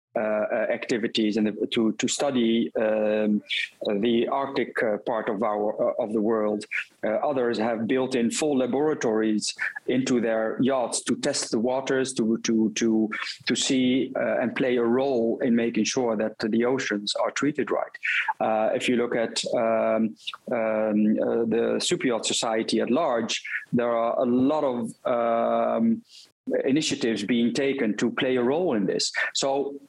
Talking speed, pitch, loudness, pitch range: 160 wpm, 115 Hz, -25 LUFS, 110-125 Hz